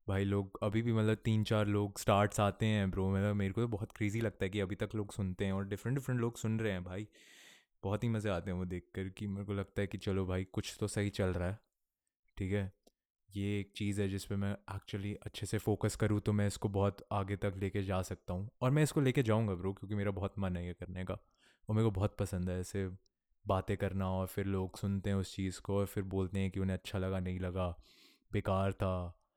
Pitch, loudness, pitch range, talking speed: 100 Hz, -37 LUFS, 95-105 Hz, 255 wpm